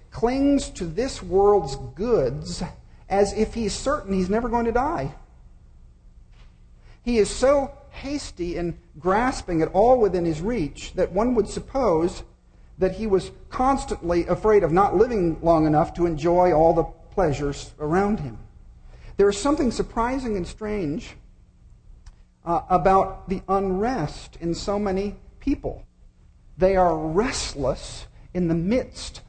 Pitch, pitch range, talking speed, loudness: 190 Hz, 165-225 Hz, 135 wpm, -23 LUFS